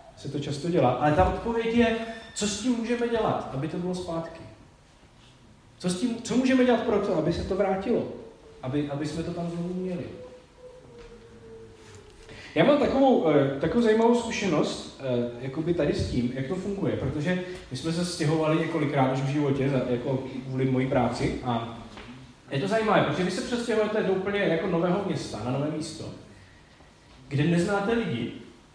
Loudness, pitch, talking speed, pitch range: -26 LUFS, 165 Hz, 170 wpm, 130-205 Hz